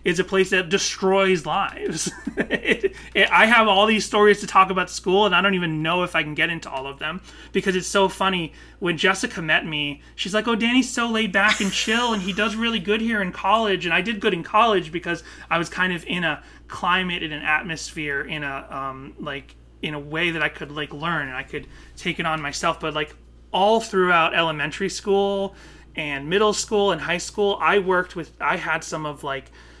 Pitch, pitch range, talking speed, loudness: 180 Hz, 155-200 Hz, 220 wpm, -21 LUFS